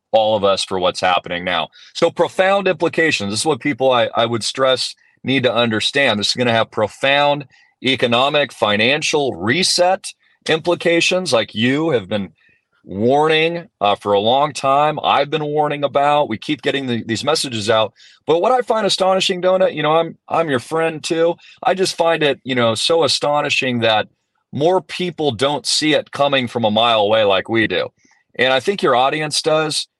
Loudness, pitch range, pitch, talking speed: -16 LUFS, 120-165 Hz, 145 Hz, 185 wpm